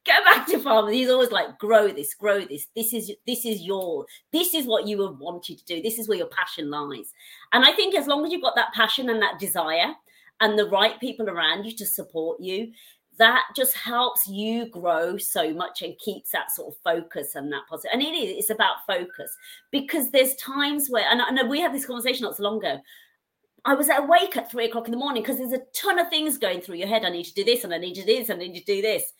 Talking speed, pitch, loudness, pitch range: 255 wpm, 225 Hz, -23 LUFS, 200-280 Hz